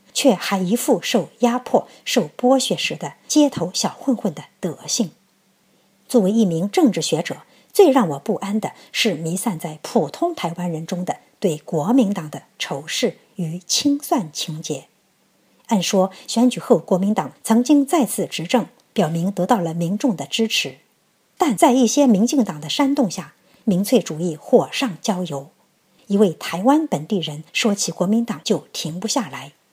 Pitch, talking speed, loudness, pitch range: 205 Hz, 235 characters per minute, -20 LUFS, 175-250 Hz